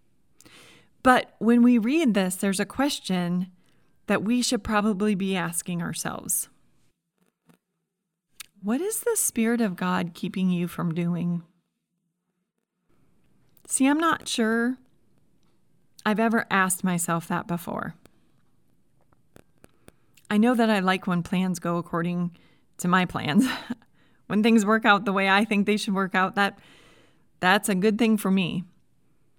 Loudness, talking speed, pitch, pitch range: -24 LUFS, 135 wpm, 195 Hz, 180-225 Hz